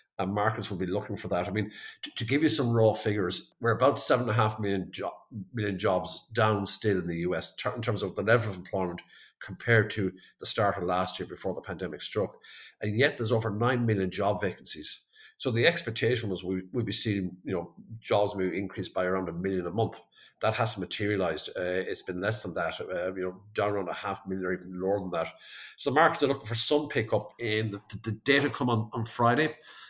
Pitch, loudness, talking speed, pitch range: 105 Hz, -29 LUFS, 225 wpm, 95-115 Hz